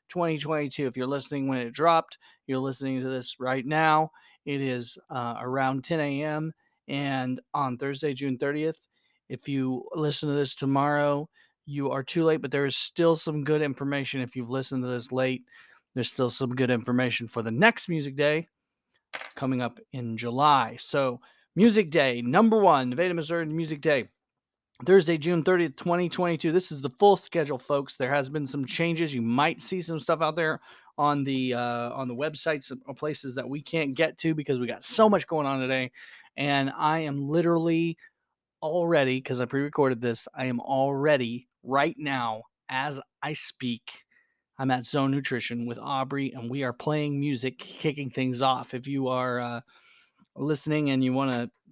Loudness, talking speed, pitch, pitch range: -27 LUFS, 180 wpm, 140 Hz, 130-155 Hz